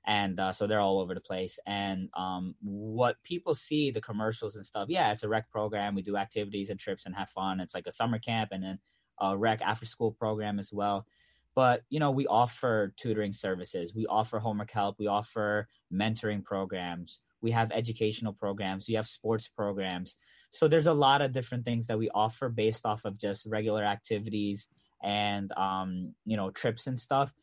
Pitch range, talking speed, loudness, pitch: 100-115 Hz, 195 wpm, -32 LUFS, 105 Hz